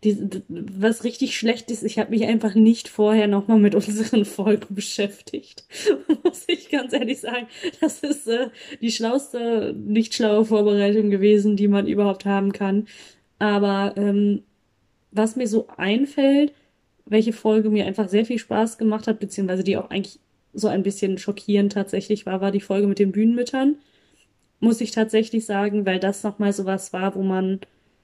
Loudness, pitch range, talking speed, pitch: -21 LUFS, 200-230 Hz, 165 wpm, 215 Hz